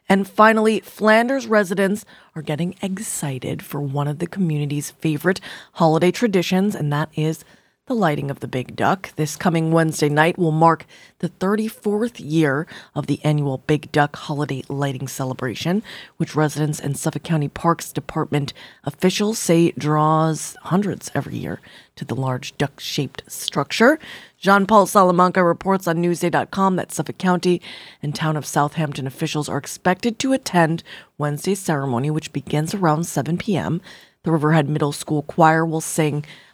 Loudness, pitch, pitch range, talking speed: -20 LUFS, 160 Hz, 150-185 Hz, 150 wpm